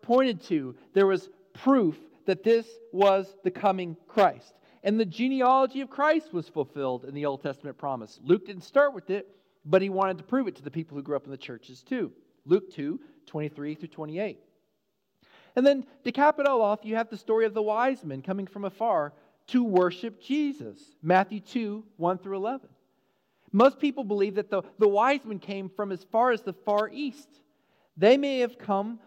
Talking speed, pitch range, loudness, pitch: 195 wpm, 180-245 Hz, -27 LUFS, 200 Hz